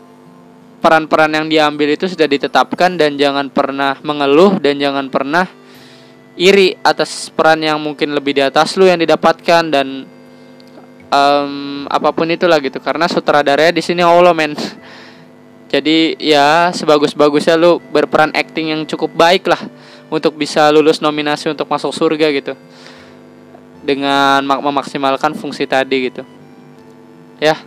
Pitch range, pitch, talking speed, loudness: 140-165 Hz, 150 Hz, 130 wpm, -13 LUFS